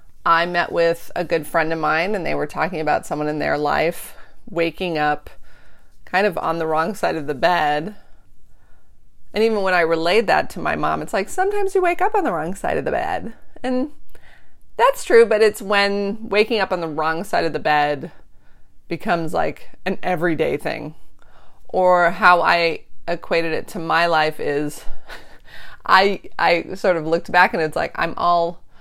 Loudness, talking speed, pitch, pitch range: -19 LUFS, 185 wpm, 175 Hz, 160-210 Hz